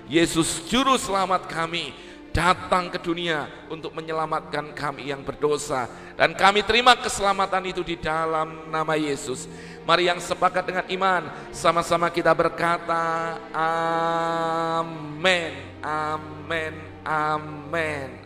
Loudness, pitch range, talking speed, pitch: -23 LUFS, 155-175 Hz, 105 wpm, 165 Hz